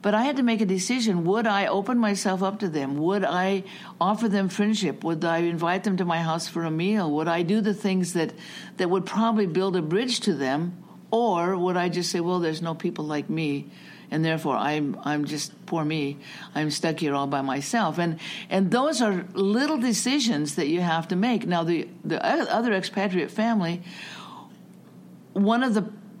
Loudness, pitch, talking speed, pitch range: -25 LUFS, 185 Hz, 200 wpm, 165-210 Hz